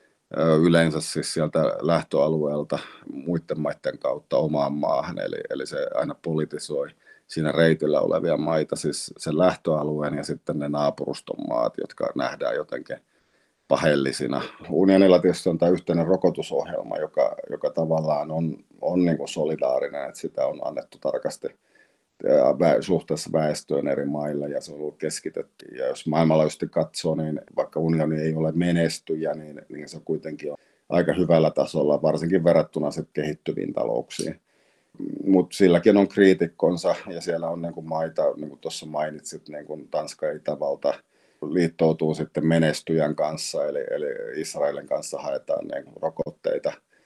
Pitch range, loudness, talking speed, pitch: 75-90 Hz, -24 LUFS, 140 wpm, 80 Hz